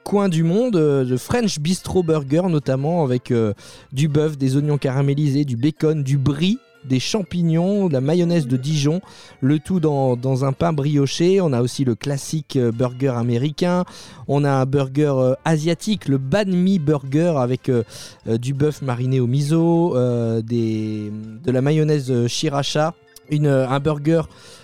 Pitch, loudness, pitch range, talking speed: 145 Hz, -20 LUFS, 130-165 Hz, 170 wpm